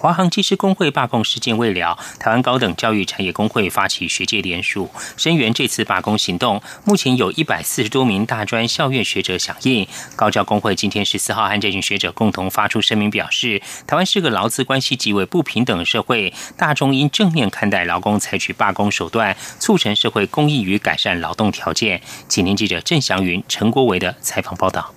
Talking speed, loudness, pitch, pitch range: 320 characters per minute, -17 LUFS, 105 Hz, 100-130 Hz